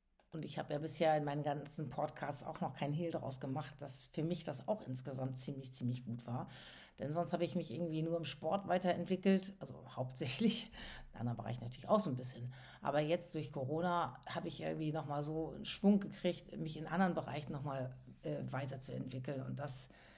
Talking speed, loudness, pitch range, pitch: 195 wpm, -40 LUFS, 130-170 Hz, 150 Hz